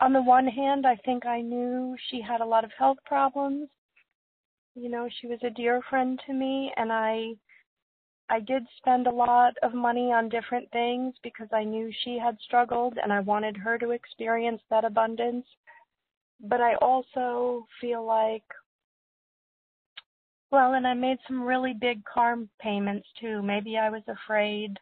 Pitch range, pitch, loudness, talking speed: 225-255 Hz, 240 Hz, -27 LUFS, 165 wpm